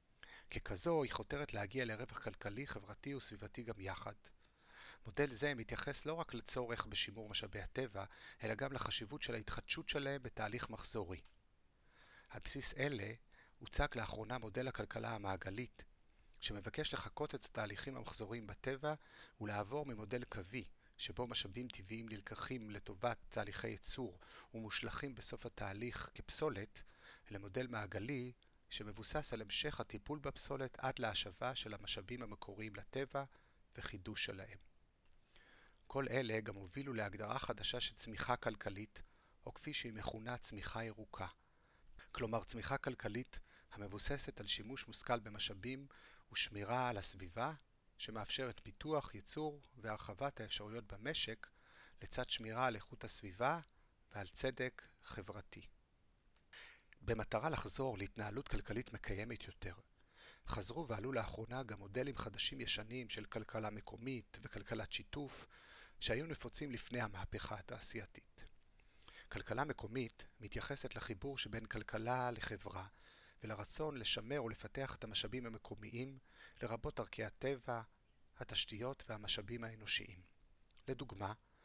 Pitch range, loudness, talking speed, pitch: 105-130 Hz, -43 LUFS, 110 wpm, 115 Hz